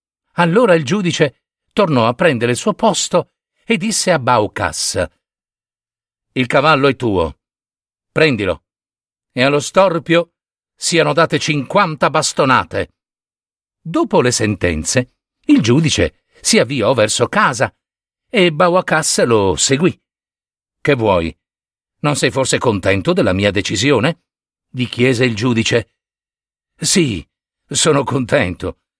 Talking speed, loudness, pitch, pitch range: 110 wpm, -15 LUFS, 140 Hz, 115-175 Hz